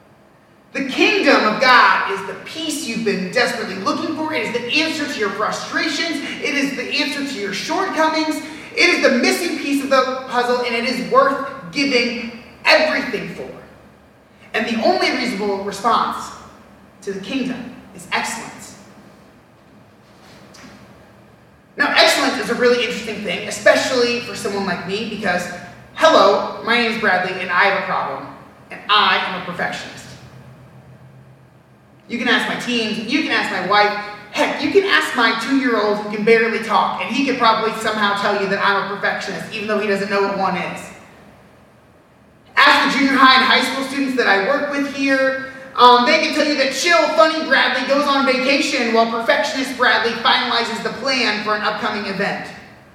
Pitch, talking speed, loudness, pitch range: 245 Hz, 175 wpm, -17 LUFS, 215-280 Hz